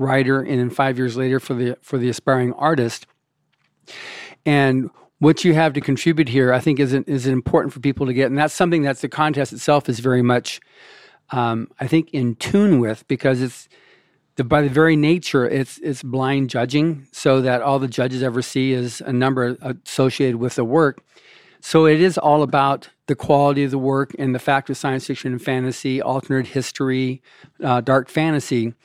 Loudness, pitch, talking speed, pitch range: -19 LUFS, 135 Hz, 195 wpm, 130-145 Hz